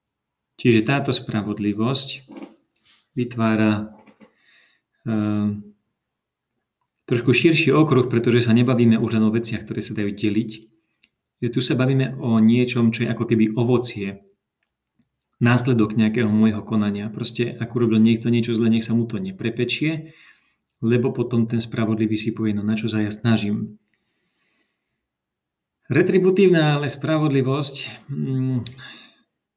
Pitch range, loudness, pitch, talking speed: 110-125 Hz, -20 LUFS, 115 Hz, 125 wpm